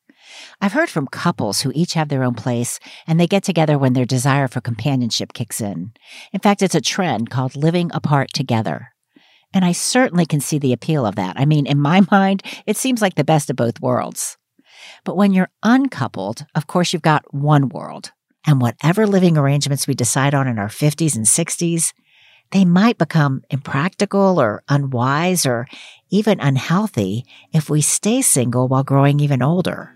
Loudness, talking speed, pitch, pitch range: -17 LUFS, 180 wpm, 150 Hz, 130-180 Hz